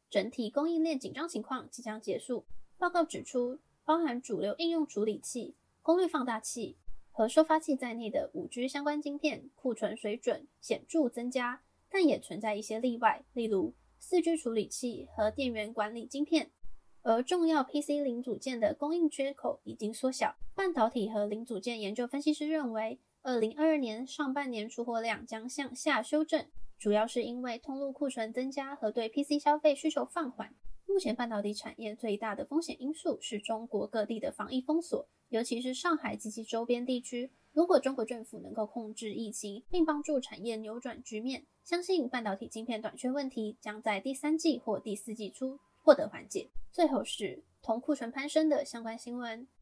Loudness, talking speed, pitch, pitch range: -34 LUFS, 280 characters per minute, 250 Hz, 220-295 Hz